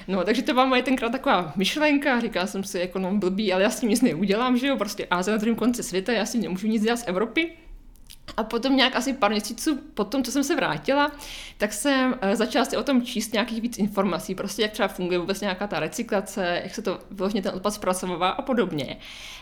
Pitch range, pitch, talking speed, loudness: 195-250 Hz, 215 Hz, 230 wpm, -24 LUFS